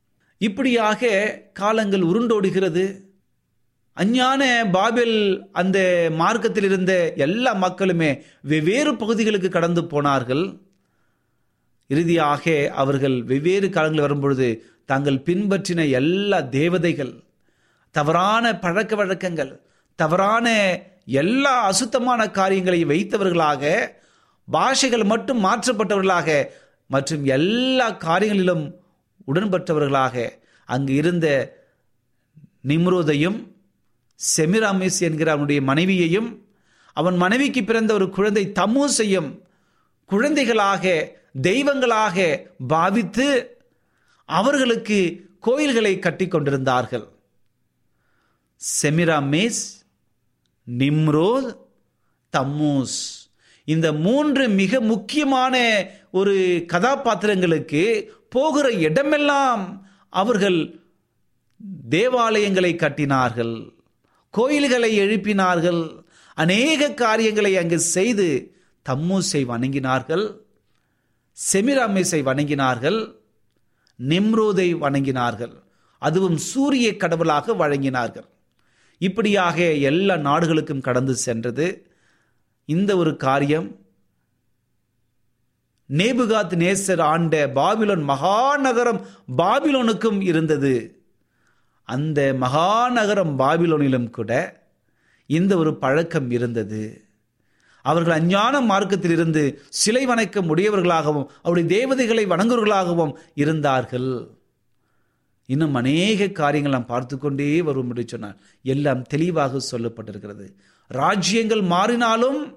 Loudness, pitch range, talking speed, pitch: -20 LUFS, 140-210 Hz, 70 wpm, 175 Hz